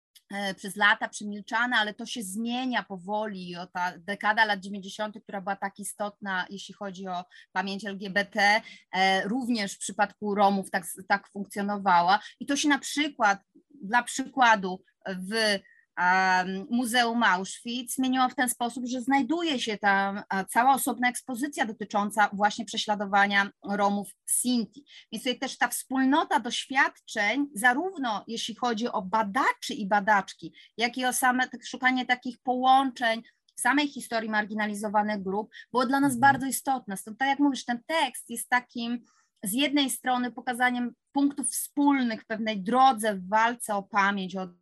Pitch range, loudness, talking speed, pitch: 200-255 Hz, -27 LUFS, 145 wpm, 225 Hz